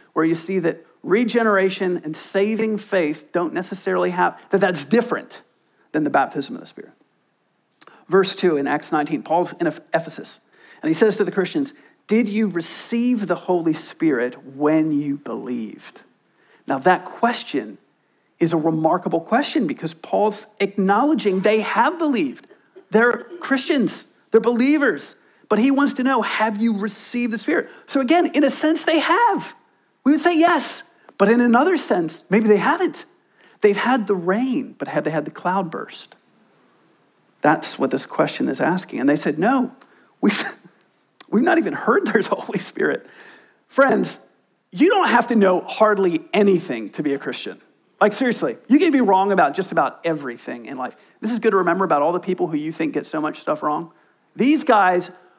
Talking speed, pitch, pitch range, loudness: 175 wpm, 205 Hz, 170-265 Hz, -20 LUFS